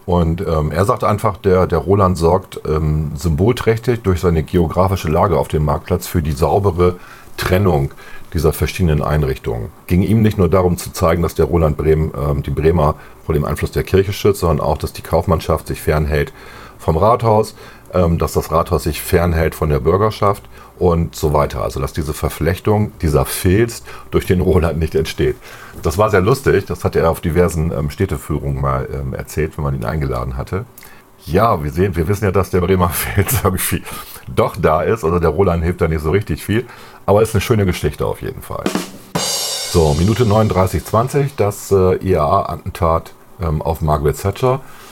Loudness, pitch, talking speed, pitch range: -17 LUFS, 85 Hz, 180 wpm, 75-100 Hz